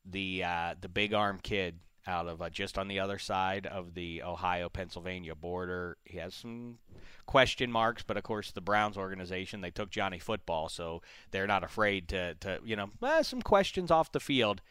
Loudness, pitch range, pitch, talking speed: -33 LUFS, 90-105 Hz, 95 Hz, 195 wpm